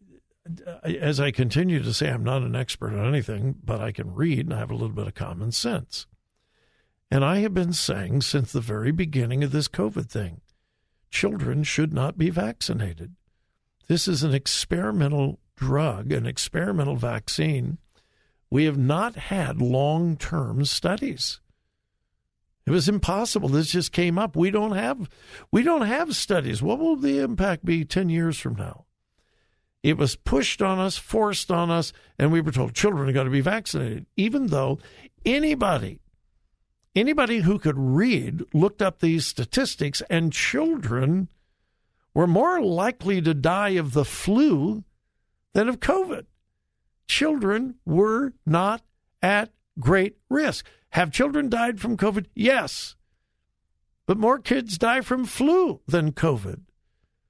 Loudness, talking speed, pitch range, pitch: -24 LUFS, 150 wpm, 135-205 Hz, 165 Hz